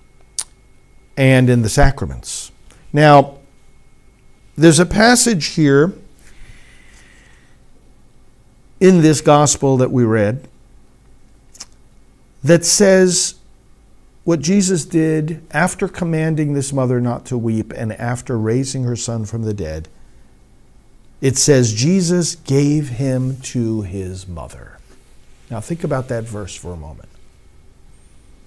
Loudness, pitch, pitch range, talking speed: -15 LUFS, 130 Hz, 110-160 Hz, 105 wpm